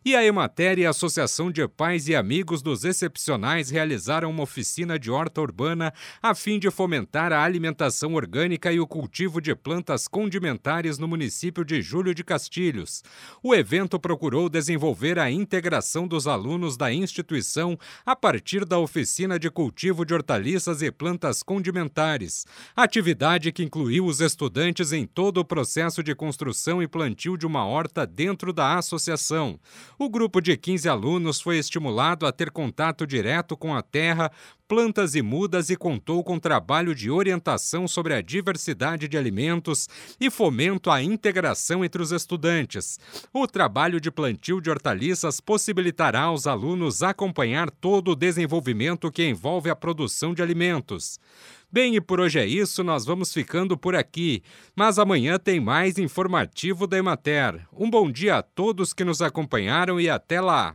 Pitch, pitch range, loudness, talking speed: 170 Hz, 155-180 Hz, -24 LUFS, 160 wpm